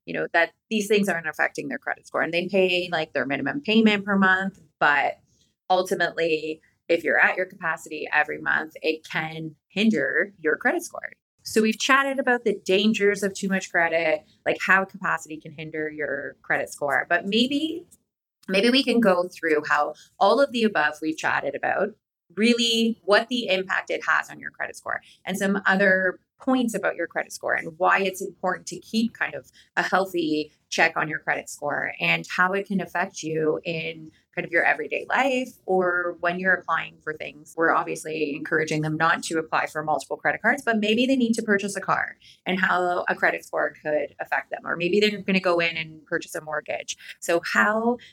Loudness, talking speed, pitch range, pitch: -24 LUFS, 195 wpm, 160-205 Hz, 180 Hz